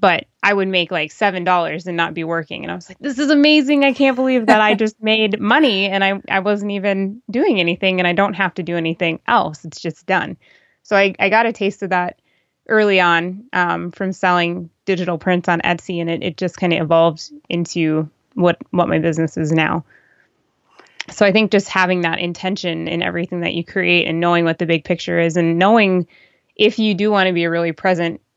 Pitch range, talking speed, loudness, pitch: 170-205 Hz, 220 wpm, -17 LUFS, 180 Hz